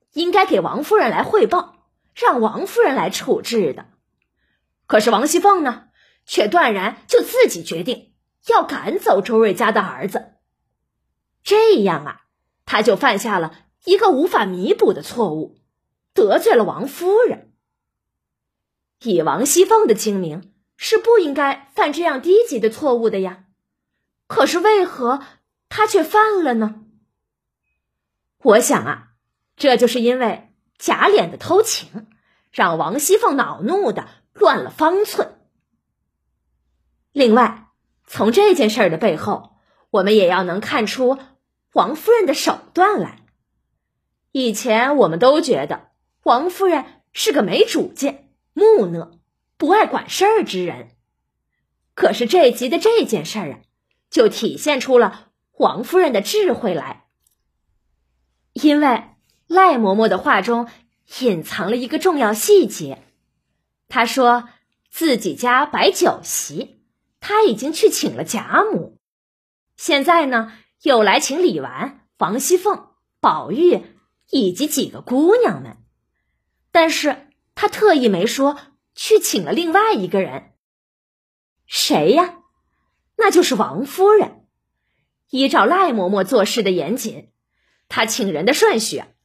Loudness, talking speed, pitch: -17 LUFS, 190 characters per minute, 280 Hz